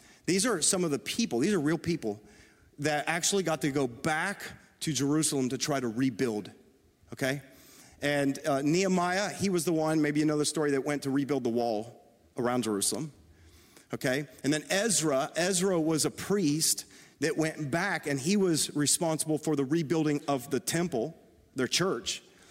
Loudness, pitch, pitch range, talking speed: -29 LUFS, 150 Hz, 130-160 Hz, 175 wpm